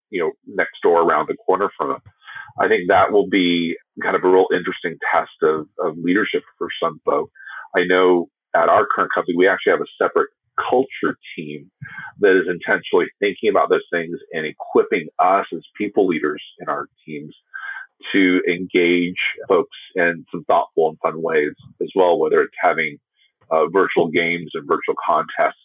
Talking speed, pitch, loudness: 175 wpm, 400 Hz, -19 LUFS